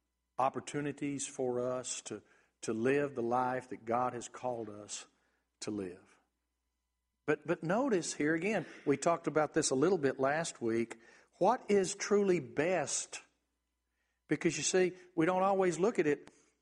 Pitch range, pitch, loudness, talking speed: 115-170 Hz, 135 Hz, -34 LUFS, 150 wpm